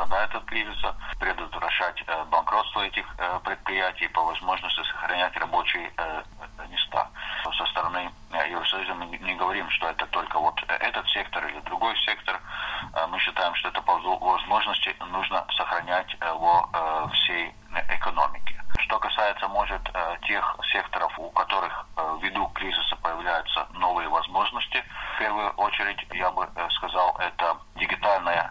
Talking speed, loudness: 120 wpm, -26 LUFS